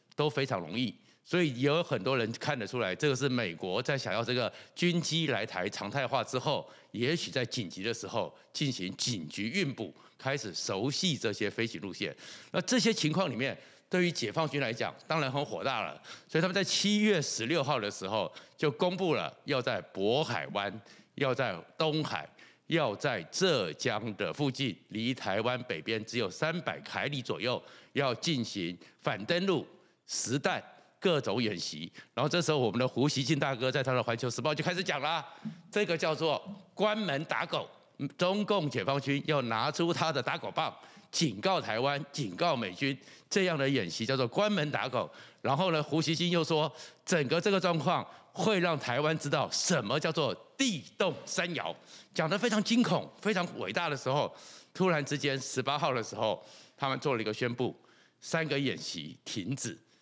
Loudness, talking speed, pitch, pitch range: -32 LUFS, 265 characters per minute, 145 Hz, 125-175 Hz